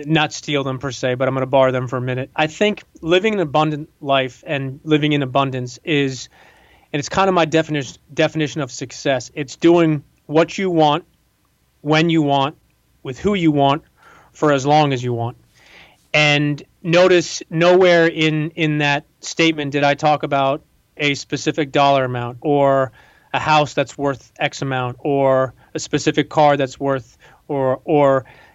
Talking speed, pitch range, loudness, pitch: 170 wpm, 135-155 Hz, -18 LUFS, 145 Hz